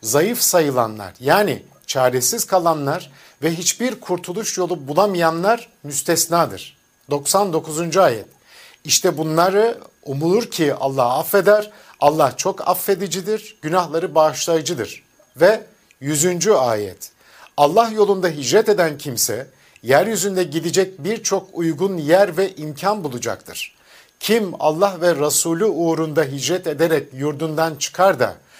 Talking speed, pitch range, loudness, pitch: 105 wpm, 155-200 Hz, -18 LUFS, 170 Hz